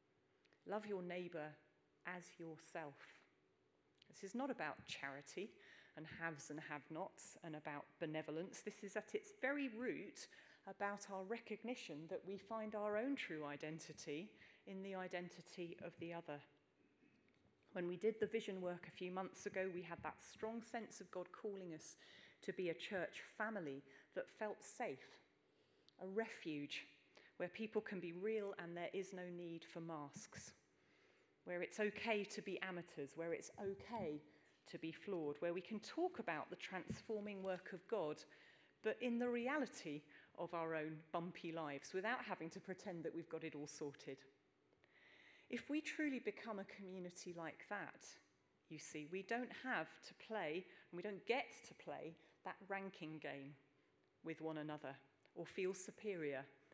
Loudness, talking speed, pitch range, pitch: -49 LUFS, 160 wpm, 155-210 Hz, 180 Hz